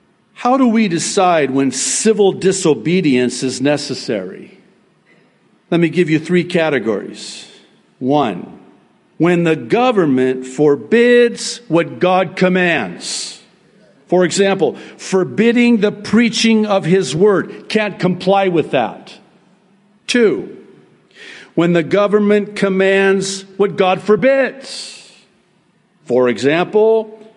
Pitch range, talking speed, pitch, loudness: 170-210 Hz, 100 wpm, 190 Hz, -14 LUFS